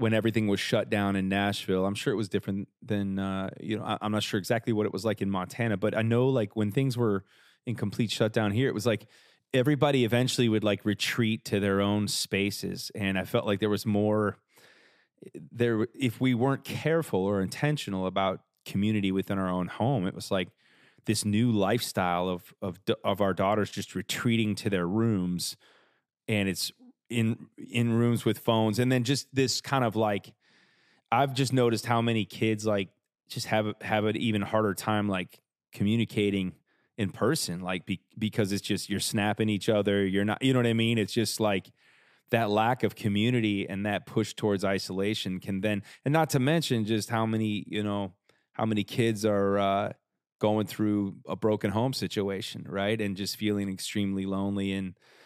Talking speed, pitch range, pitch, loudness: 190 wpm, 100-115 Hz, 105 Hz, -28 LUFS